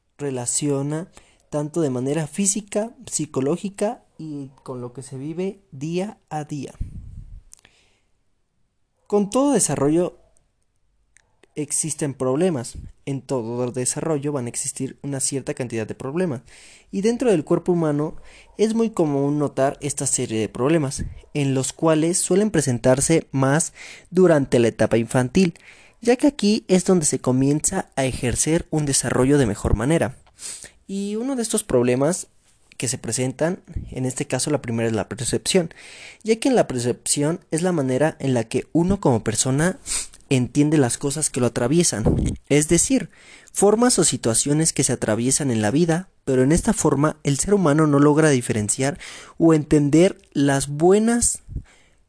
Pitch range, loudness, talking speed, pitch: 130-170 Hz, -21 LUFS, 150 wpm, 145 Hz